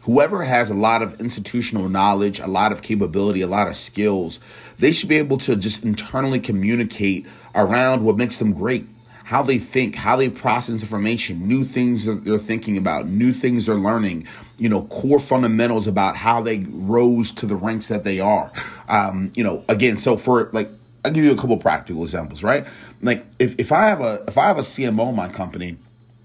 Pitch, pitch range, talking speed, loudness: 110 Hz, 100-120 Hz, 205 wpm, -20 LUFS